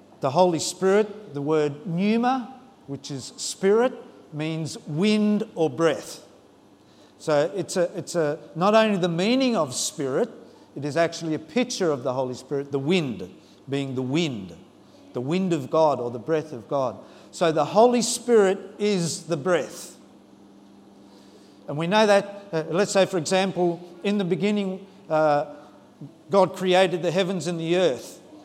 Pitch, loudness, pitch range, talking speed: 170 Hz, -24 LUFS, 145-200 Hz, 155 wpm